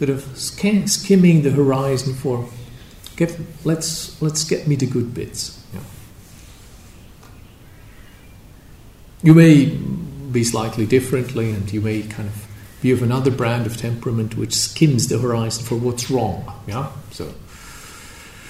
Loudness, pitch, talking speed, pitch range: -18 LUFS, 120 Hz, 135 wpm, 110-140 Hz